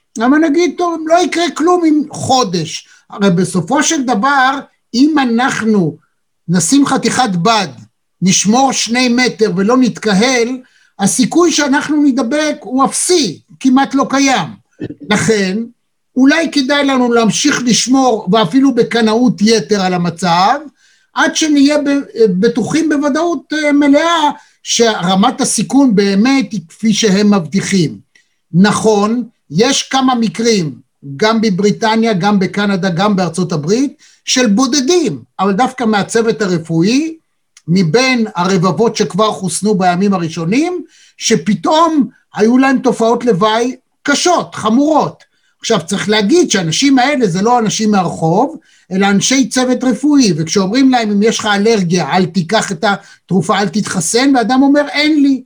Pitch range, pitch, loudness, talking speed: 200-275 Hz, 230 Hz, -12 LUFS, 120 wpm